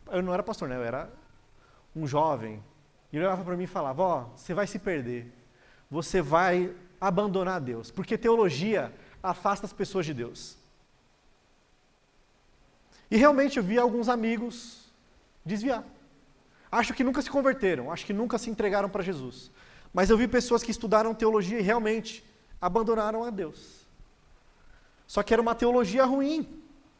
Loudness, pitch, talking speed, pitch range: -28 LUFS, 205 Hz, 155 wpm, 180-235 Hz